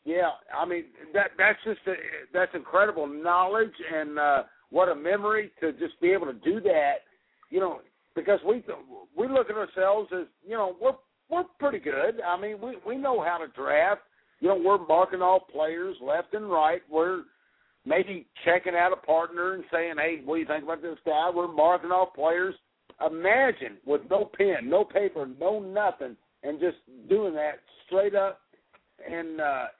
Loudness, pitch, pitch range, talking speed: -27 LUFS, 185 Hz, 165-215 Hz, 180 wpm